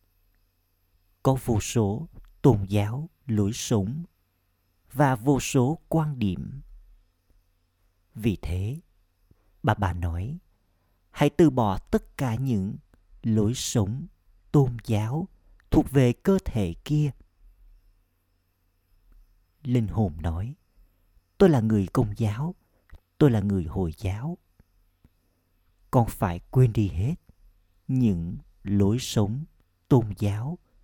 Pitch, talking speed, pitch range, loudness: 100 Hz, 105 wpm, 90-130 Hz, -26 LUFS